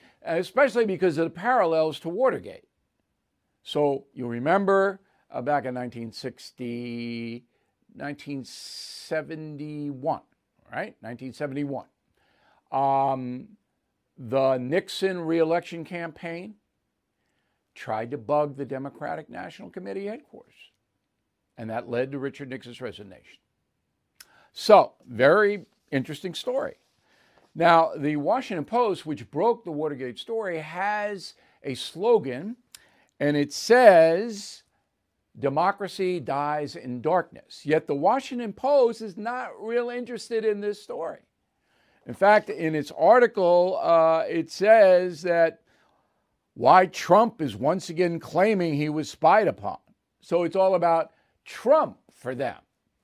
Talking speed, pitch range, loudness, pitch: 110 wpm, 140-200 Hz, -24 LUFS, 165 Hz